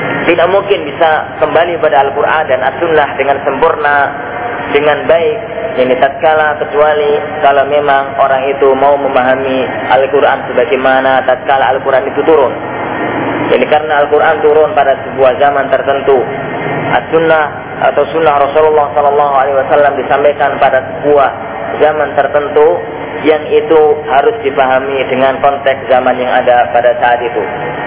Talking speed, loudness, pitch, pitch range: 125 wpm, -10 LUFS, 145 Hz, 135-150 Hz